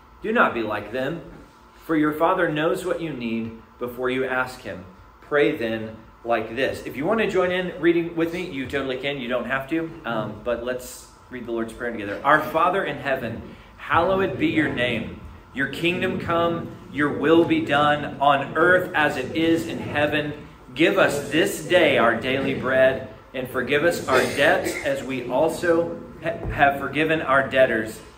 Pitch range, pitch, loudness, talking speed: 120-165 Hz, 135 Hz, -22 LUFS, 180 wpm